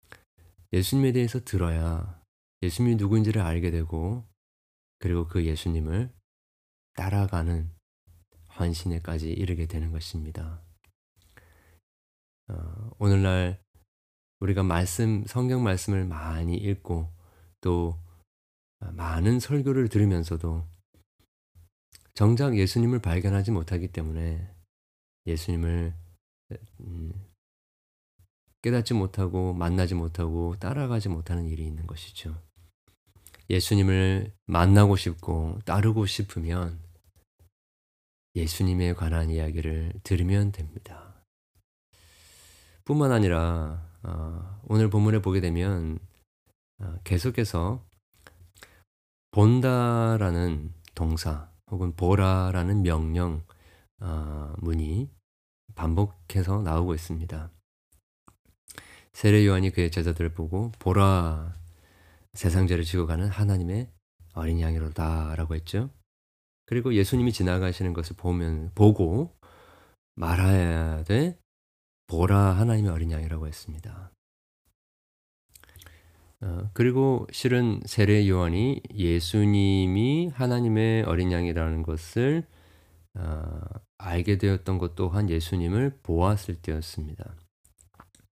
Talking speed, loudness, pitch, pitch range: 220 characters per minute, -26 LUFS, 90 Hz, 80-100 Hz